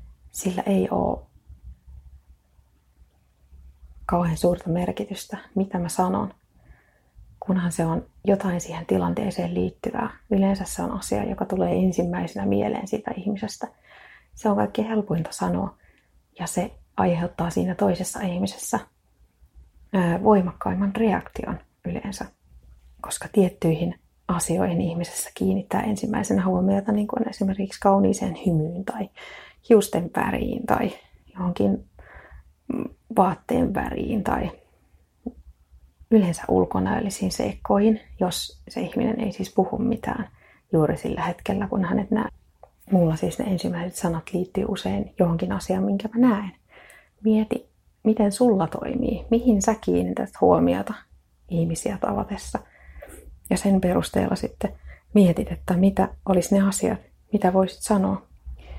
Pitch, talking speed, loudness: 185 Hz, 115 wpm, -24 LUFS